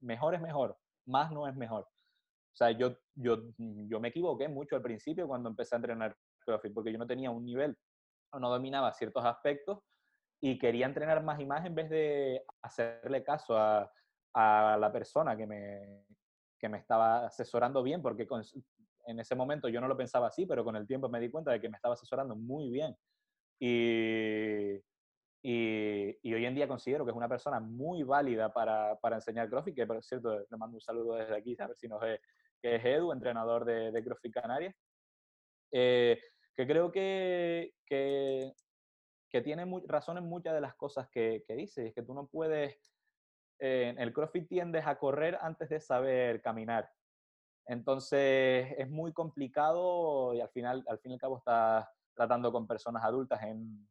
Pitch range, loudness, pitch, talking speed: 115-145 Hz, -35 LUFS, 125 Hz, 185 wpm